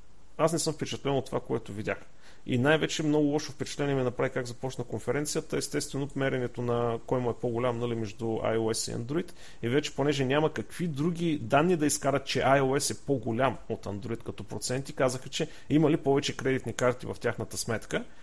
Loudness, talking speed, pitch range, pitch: -30 LUFS, 190 wpm, 115-145 Hz, 130 Hz